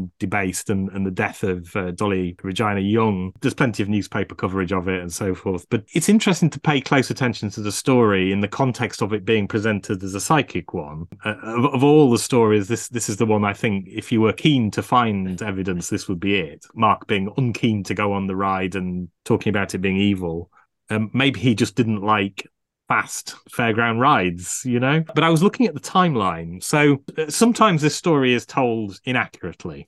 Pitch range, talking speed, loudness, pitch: 95-125 Hz, 210 wpm, -20 LUFS, 110 Hz